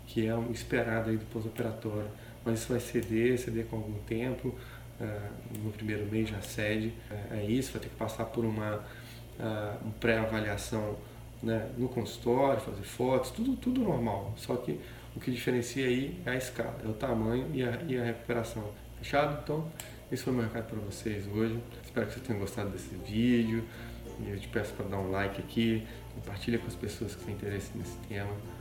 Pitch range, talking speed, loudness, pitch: 110-120 Hz, 195 wpm, -34 LUFS, 115 Hz